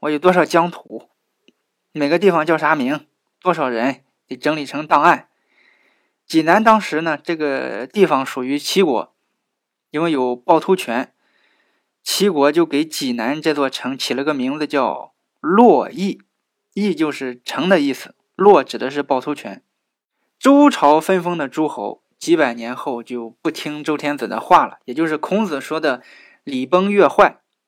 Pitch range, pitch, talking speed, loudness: 140-185 Hz, 155 Hz, 230 characters per minute, -17 LUFS